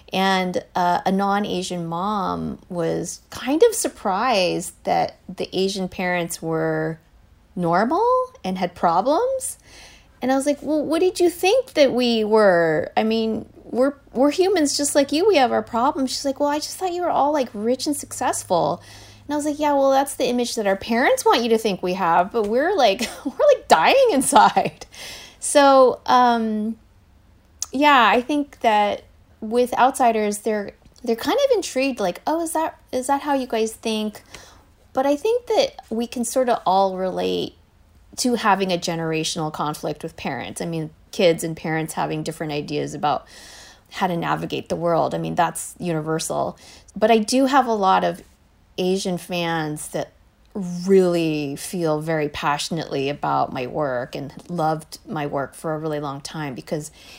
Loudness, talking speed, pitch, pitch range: -21 LUFS, 175 wpm, 210 Hz, 165-270 Hz